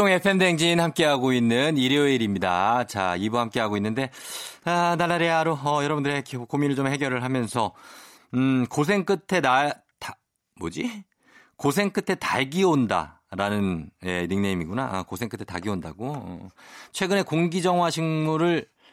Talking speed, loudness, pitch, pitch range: 305 characters per minute, -24 LUFS, 145 Hz, 115-175 Hz